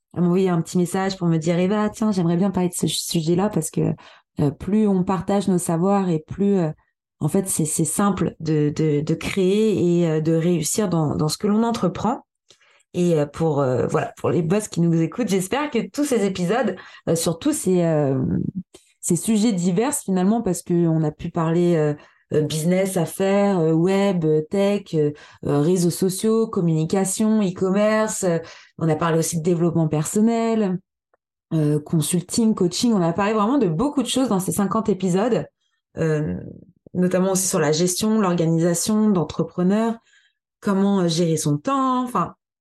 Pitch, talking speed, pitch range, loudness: 180 Hz, 180 wpm, 165-205 Hz, -21 LUFS